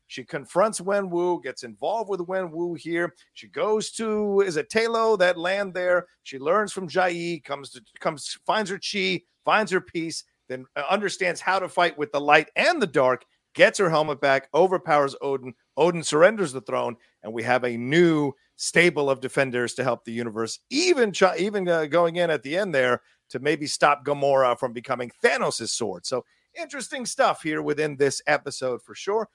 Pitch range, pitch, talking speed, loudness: 140-190 Hz, 165 Hz, 180 wpm, -24 LUFS